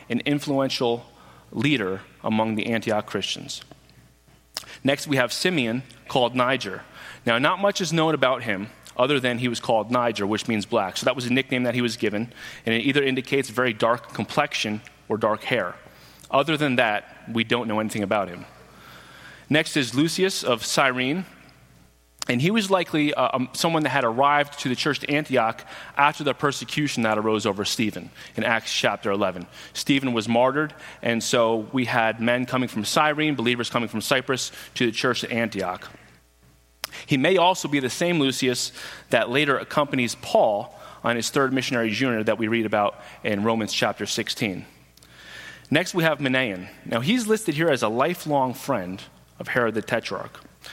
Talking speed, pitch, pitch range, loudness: 175 wpm, 125 Hz, 110-145 Hz, -23 LUFS